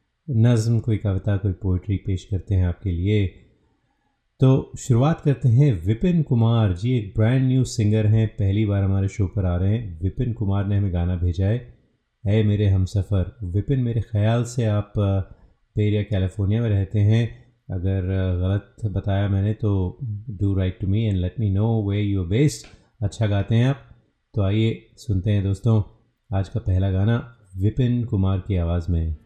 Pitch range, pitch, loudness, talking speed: 95-115 Hz, 105 Hz, -22 LUFS, 175 wpm